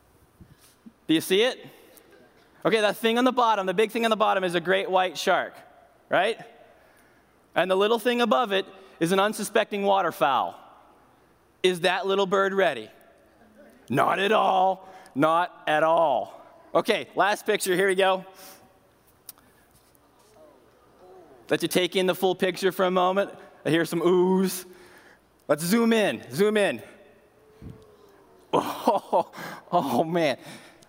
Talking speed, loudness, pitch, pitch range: 140 wpm, -24 LUFS, 190 Hz, 185-220 Hz